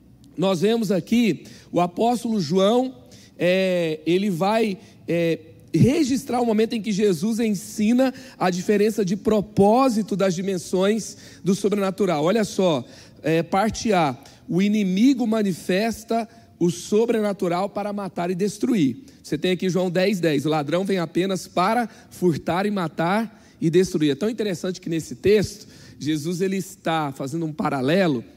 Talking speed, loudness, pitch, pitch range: 140 wpm, -22 LUFS, 190 Hz, 170-215 Hz